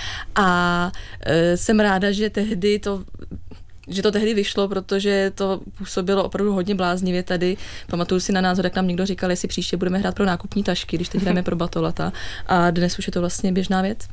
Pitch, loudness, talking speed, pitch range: 185 Hz, -21 LUFS, 195 wpm, 175-200 Hz